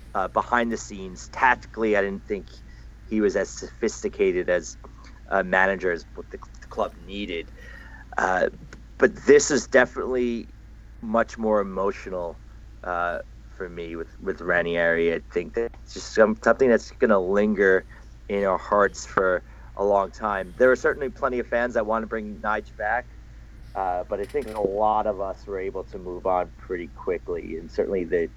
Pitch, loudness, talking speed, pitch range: 105 Hz, -24 LUFS, 175 wpm, 90-115 Hz